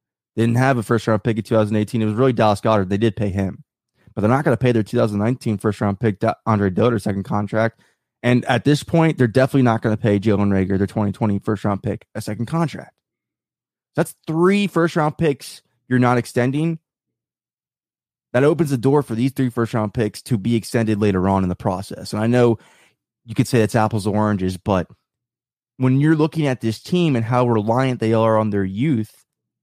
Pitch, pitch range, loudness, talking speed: 115 Hz, 105-130 Hz, -19 LUFS, 210 wpm